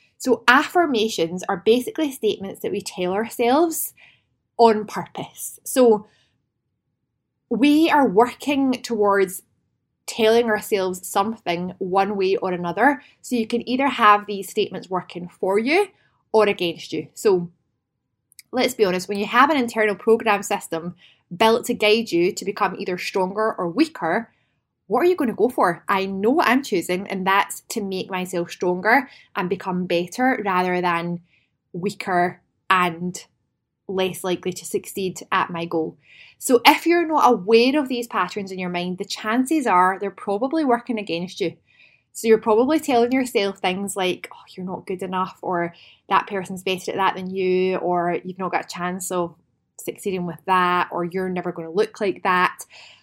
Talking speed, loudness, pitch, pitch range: 165 wpm, -21 LUFS, 195 Hz, 180-230 Hz